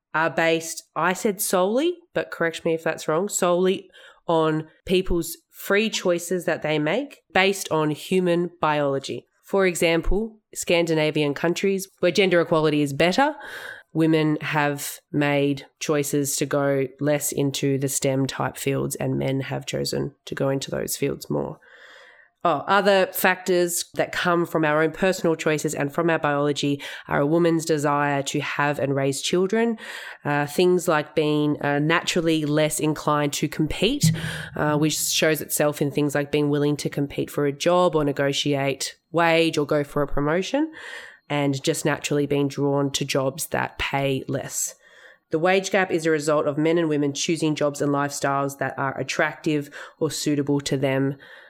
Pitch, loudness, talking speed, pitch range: 155 Hz, -23 LUFS, 165 wpm, 145-175 Hz